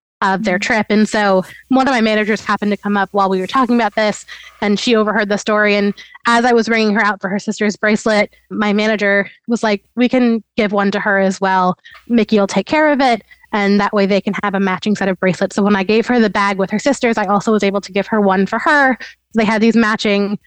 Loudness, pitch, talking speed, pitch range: -15 LUFS, 210 Hz, 260 wpm, 200-225 Hz